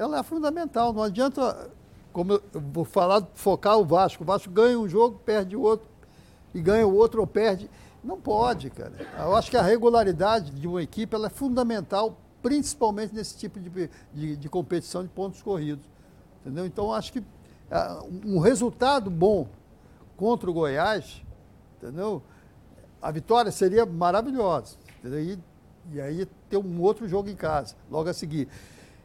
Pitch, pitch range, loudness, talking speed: 195 Hz, 170-220 Hz, -26 LUFS, 160 wpm